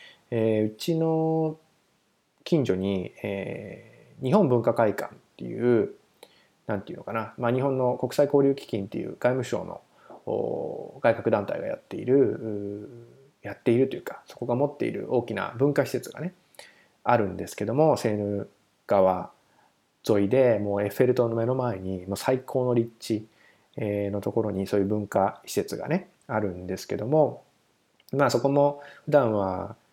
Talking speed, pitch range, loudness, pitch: 300 characters per minute, 100-140 Hz, -26 LUFS, 120 Hz